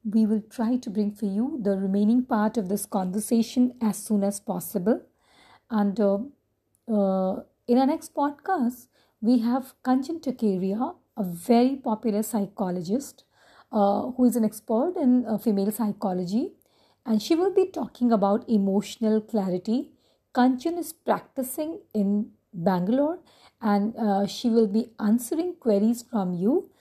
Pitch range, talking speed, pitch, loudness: 205-255 Hz, 140 wpm, 225 Hz, -25 LUFS